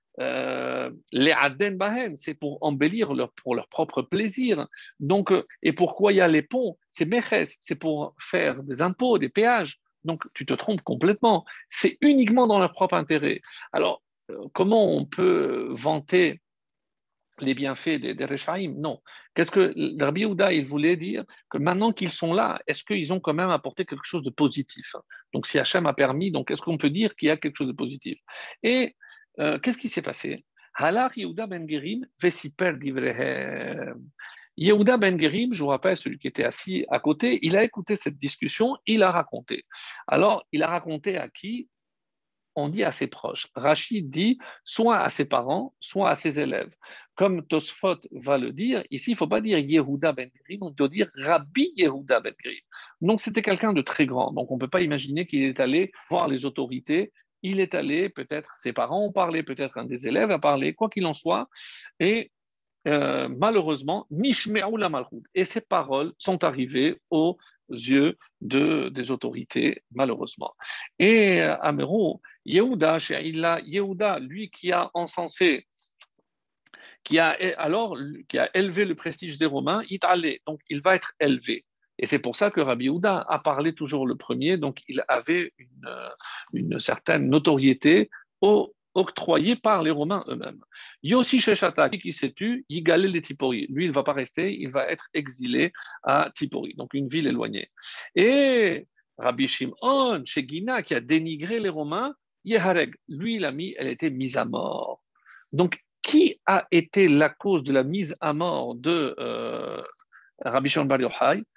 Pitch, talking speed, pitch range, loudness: 180 Hz, 170 wpm, 150-220 Hz, -25 LUFS